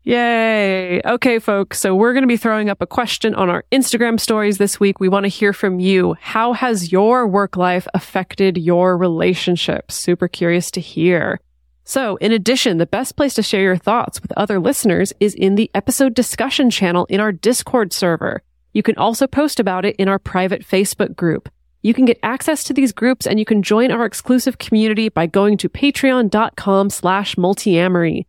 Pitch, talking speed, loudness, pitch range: 205 Hz, 190 wpm, -16 LUFS, 185-235 Hz